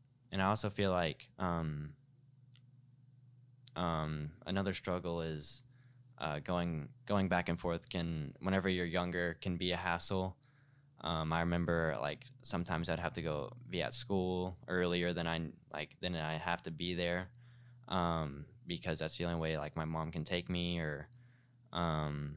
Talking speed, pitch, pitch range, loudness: 160 wpm, 90 Hz, 80-105 Hz, -37 LUFS